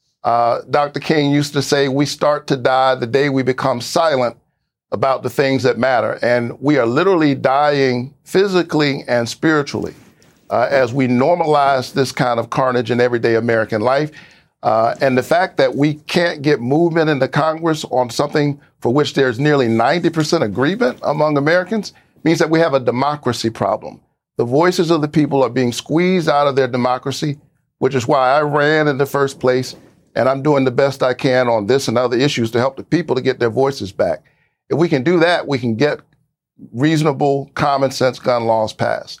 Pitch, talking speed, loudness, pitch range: 140 Hz, 190 wpm, -16 LUFS, 125-150 Hz